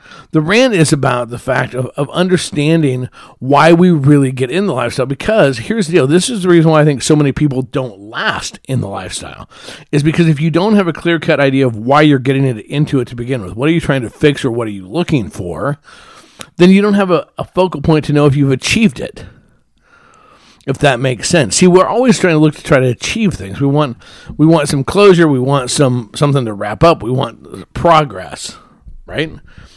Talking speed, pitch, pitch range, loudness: 225 wpm, 145 Hz, 130-170 Hz, -12 LUFS